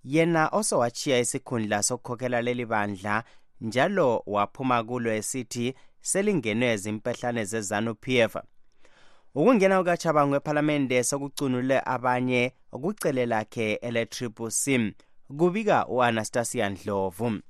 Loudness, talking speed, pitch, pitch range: -26 LUFS, 80 wpm, 125 Hz, 110-140 Hz